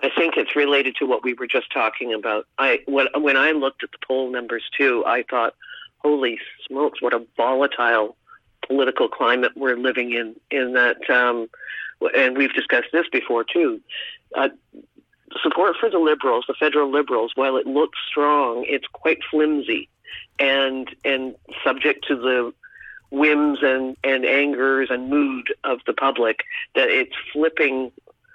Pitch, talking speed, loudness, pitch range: 140 Hz, 155 wpm, -20 LUFS, 130-160 Hz